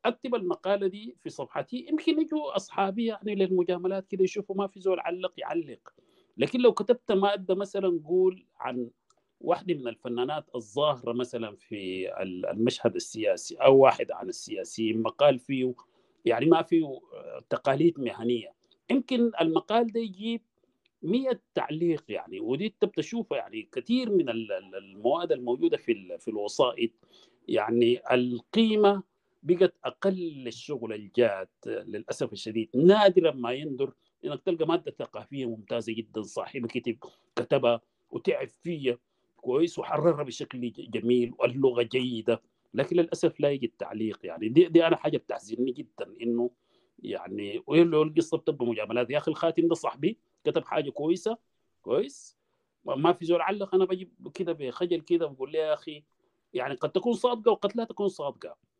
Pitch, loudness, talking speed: 170 Hz, -28 LUFS, 135 wpm